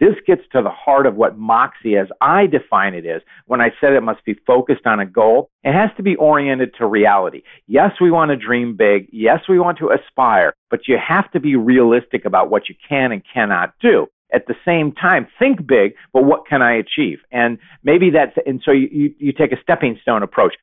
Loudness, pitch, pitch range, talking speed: -15 LUFS, 150 Hz, 130-180 Hz, 225 wpm